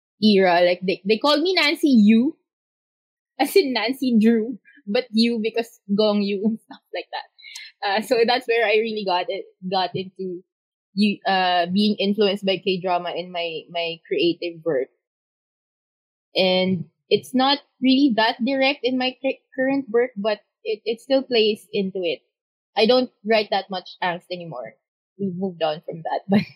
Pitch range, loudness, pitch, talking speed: 190-260 Hz, -21 LUFS, 215 Hz, 165 wpm